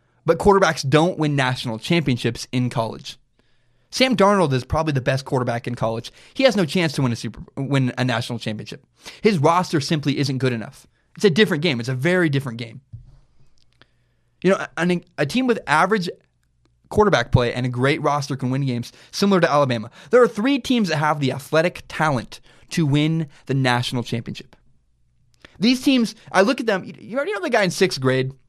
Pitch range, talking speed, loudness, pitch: 125-180 Hz, 190 wpm, -20 LUFS, 140 Hz